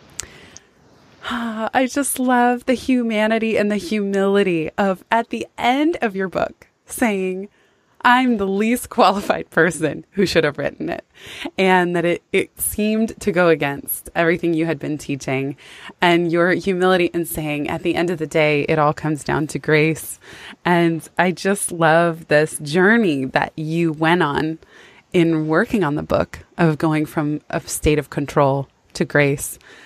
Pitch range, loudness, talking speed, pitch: 155-205 Hz, -19 LUFS, 160 wpm, 170 Hz